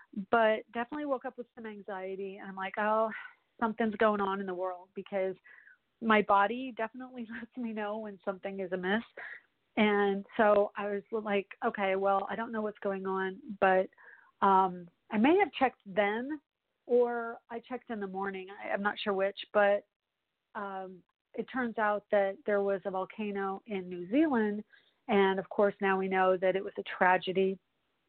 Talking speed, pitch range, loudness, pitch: 175 wpm, 195-230 Hz, -31 LUFS, 205 Hz